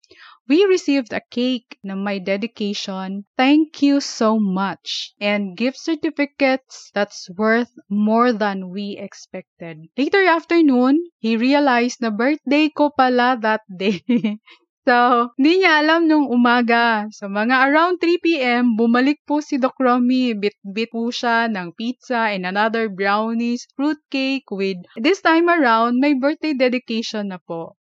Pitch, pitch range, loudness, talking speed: 245 Hz, 210-285 Hz, -18 LUFS, 140 wpm